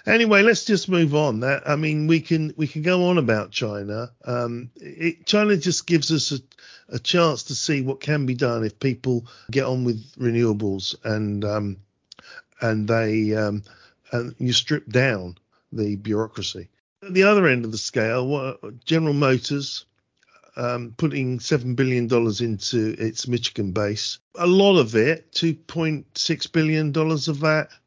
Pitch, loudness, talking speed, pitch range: 130 Hz, -22 LUFS, 165 wpm, 110-155 Hz